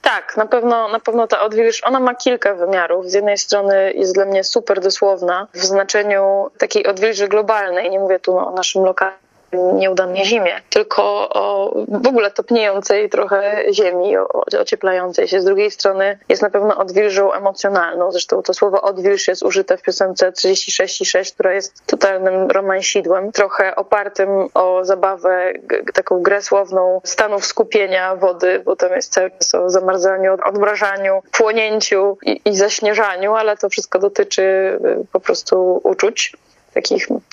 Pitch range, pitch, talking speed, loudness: 190-215 Hz, 200 Hz, 150 wpm, -16 LUFS